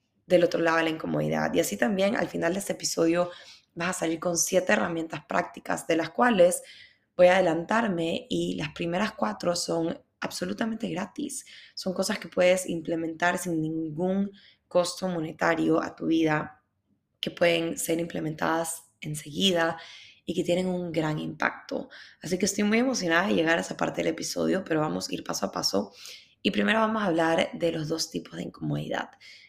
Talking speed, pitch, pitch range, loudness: 175 wpm, 170 Hz, 160-185 Hz, -27 LUFS